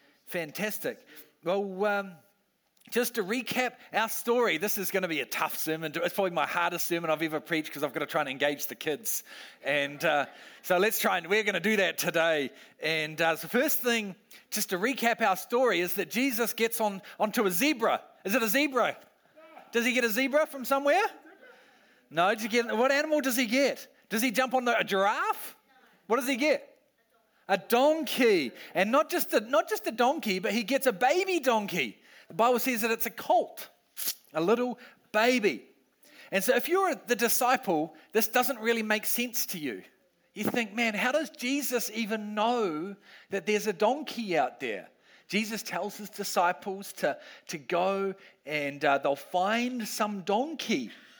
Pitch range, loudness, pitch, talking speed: 190-250 Hz, -28 LUFS, 225 Hz, 190 wpm